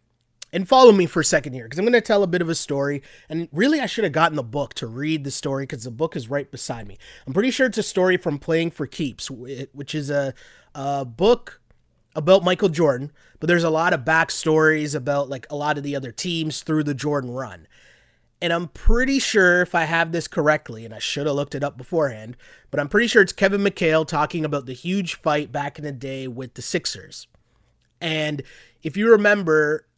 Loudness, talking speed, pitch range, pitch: -21 LUFS, 225 wpm, 140-170 Hz, 150 Hz